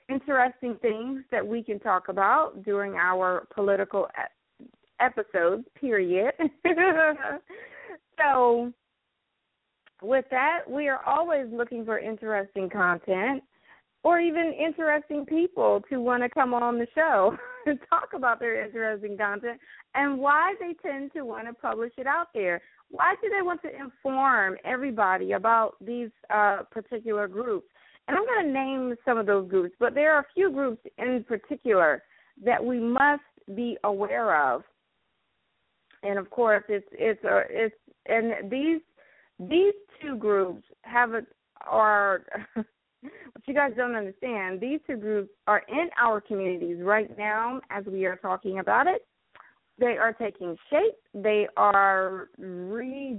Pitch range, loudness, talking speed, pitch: 210-290 Hz, -26 LUFS, 145 wpm, 240 Hz